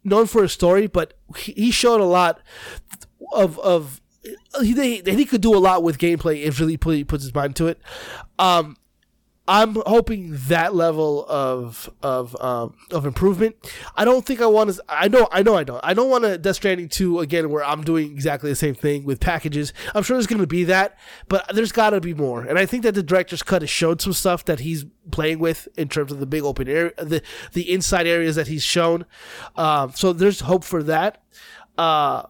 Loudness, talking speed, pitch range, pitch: -20 LUFS, 220 wpm, 150-200 Hz, 170 Hz